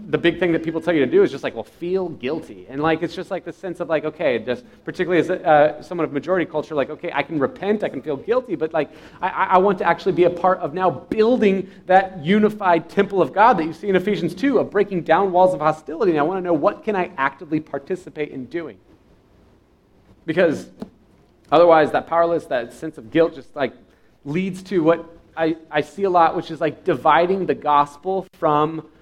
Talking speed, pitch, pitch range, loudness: 225 wpm, 170 Hz, 155-185 Hz, -20 LUFS